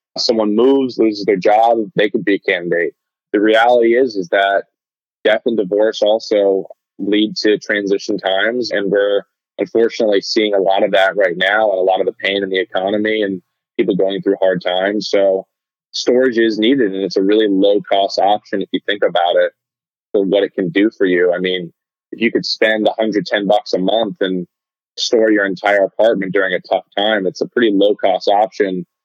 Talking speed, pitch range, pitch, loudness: 200 wpm, 95-110 Hz, 100 Hz, -15 LUFS